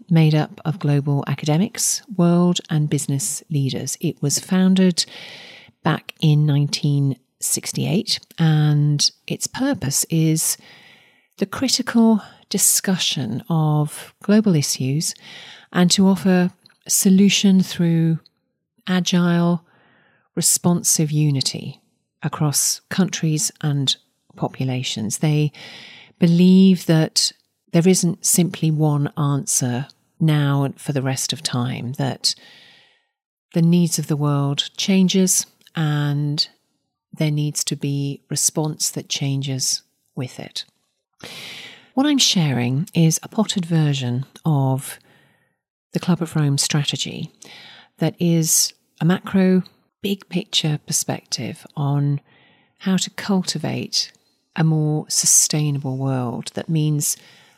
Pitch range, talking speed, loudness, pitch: 145-180 Hz, 100 wpm, -19 LUFS, 160 Hz